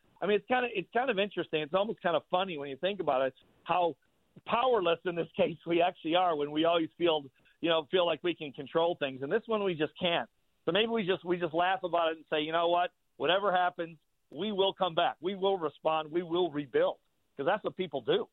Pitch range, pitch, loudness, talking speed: 160-190 Hz, 175 Hz, -31 LUFS, 250 wpm